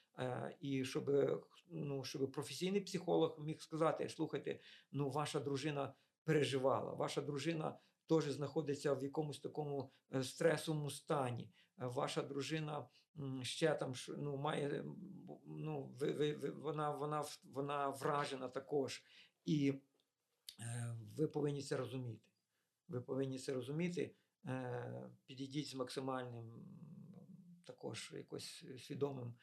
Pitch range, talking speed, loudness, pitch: 130-155 Hz, 100 wpm, -42 LUFS, 140 Hz